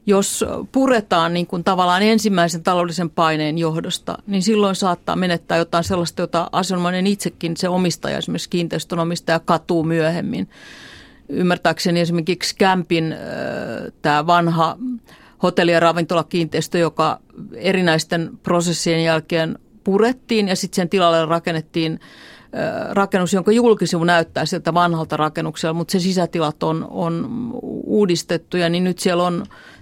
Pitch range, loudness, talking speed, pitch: 165-190 Hz, -19 LUFS, 125 wpm, 175 Hz